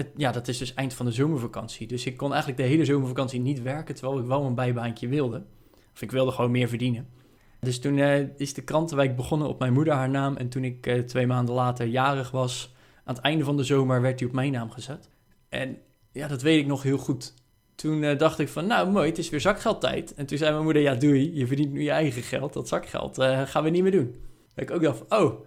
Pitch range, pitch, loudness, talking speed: 125-145 Hz, 135 Hz, -26 LUFS, 250 wpm